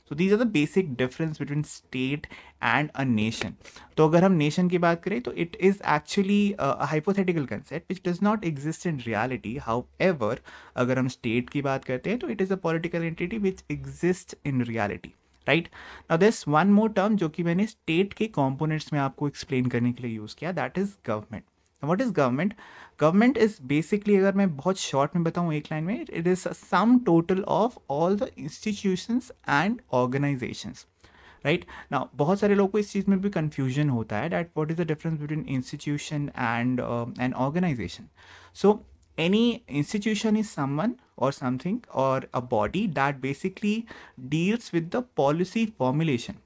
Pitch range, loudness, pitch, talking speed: 135-195 Hz, -26 LUFS, 160 Hz, 165 wpm